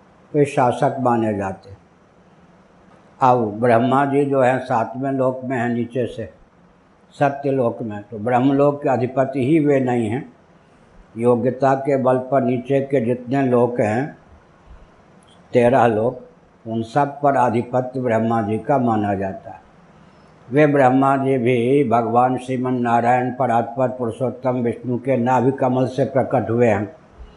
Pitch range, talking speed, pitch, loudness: 115-135 Hz, 140 wpm, 125 Hz, -19 LUFS